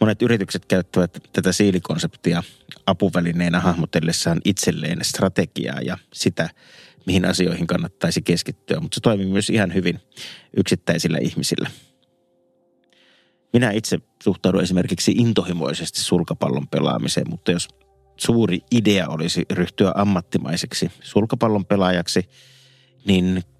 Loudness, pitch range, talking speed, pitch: -21 LUFS, 85-110 Hz, 100 wpm, 95 Hz